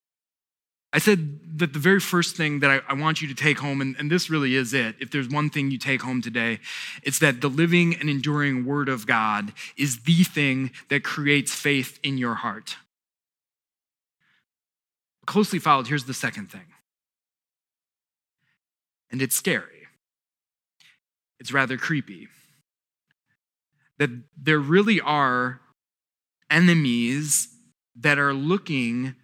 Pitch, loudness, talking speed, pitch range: 145 Hz, -23 LUFS, 135 wpm, 130-155 Hz